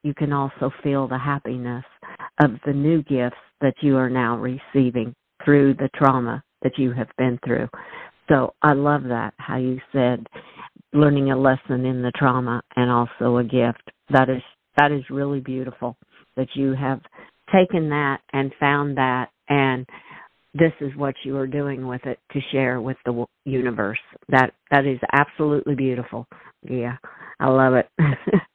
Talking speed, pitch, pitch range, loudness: 160 wpm, 130 Hz, 125-140 Hz, -22 LUFS